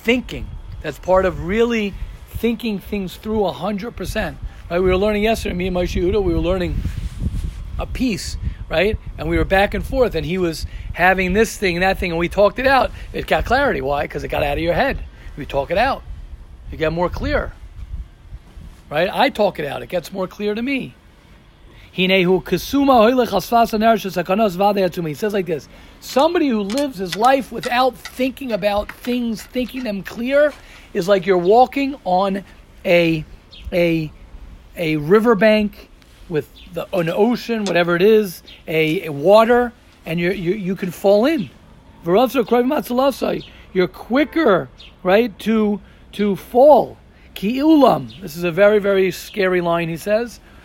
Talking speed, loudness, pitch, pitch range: 155 wpm, -18 LUFS, 200 Hz, 180-230 Hz